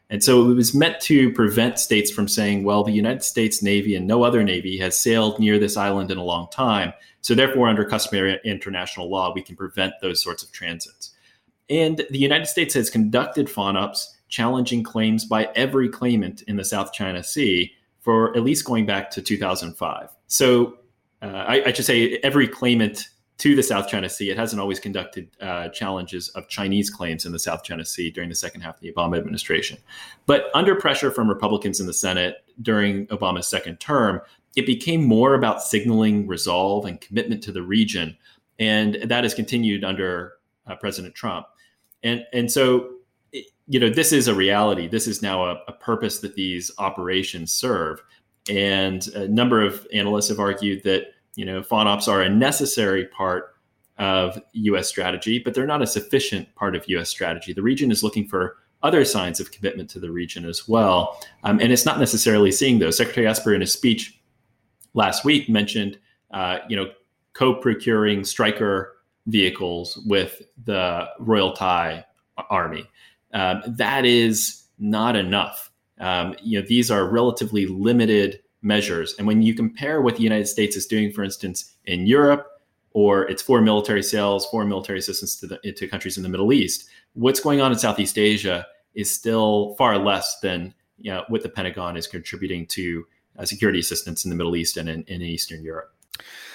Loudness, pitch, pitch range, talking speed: -21 LUFS, 105 Hz, 95-115 Hz, 180 wpm